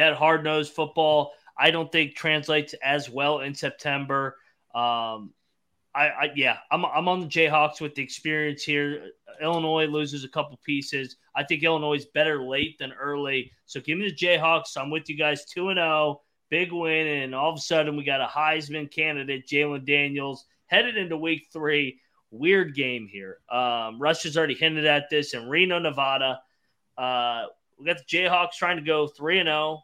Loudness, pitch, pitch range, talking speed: -25 LUFS, 150 Hz, 140-160 Hz, 185 wpm